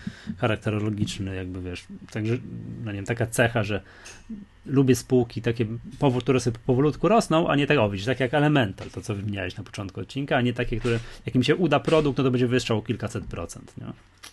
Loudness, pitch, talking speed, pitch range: -25 LUFS, 120 Hz, 185 wpm, 105-130 Hz